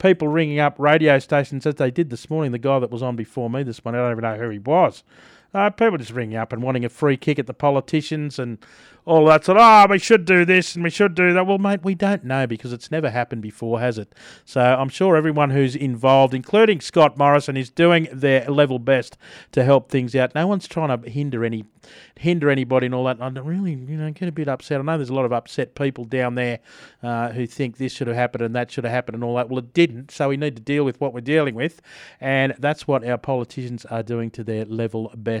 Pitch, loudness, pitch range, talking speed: 135 Hz, -20 LUFS, 125-155 Hz, 260 wpm